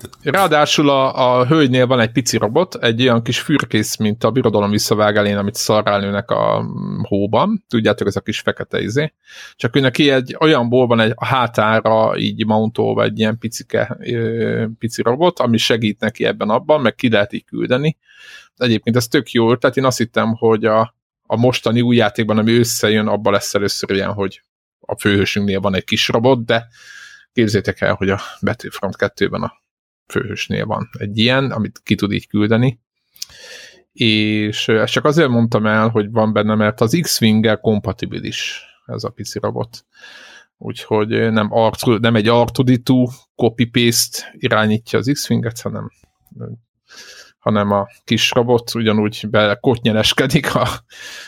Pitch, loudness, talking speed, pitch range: 115 Hz, -16 LUFS, 155 wpm, 110-125 Hz